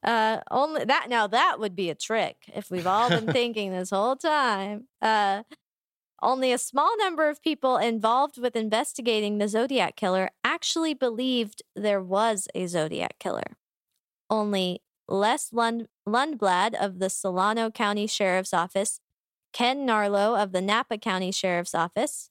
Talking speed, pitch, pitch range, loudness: 150 wpm, 220 Hz, 195-250 Hz, -26 LUFS